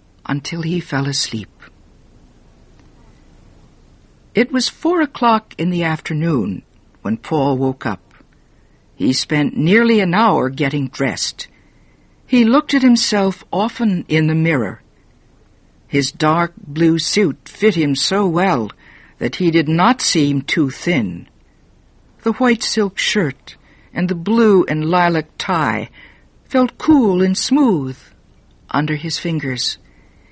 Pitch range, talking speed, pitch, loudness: 140-215 Hz, 125 wpm, 165 Hz, -16 LUFS